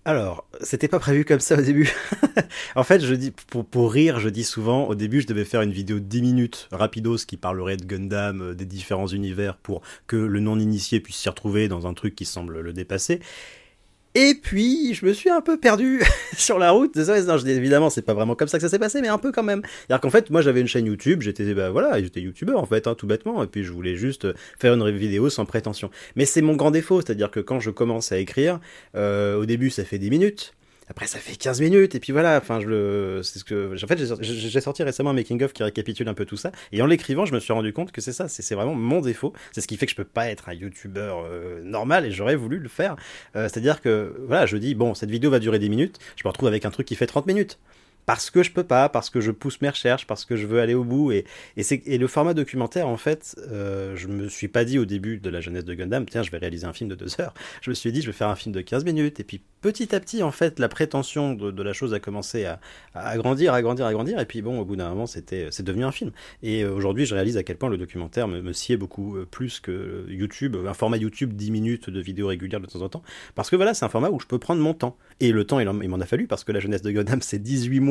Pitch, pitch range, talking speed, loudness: 115 Hz, 100-140 Hz, 280 wpm, -23 LUFS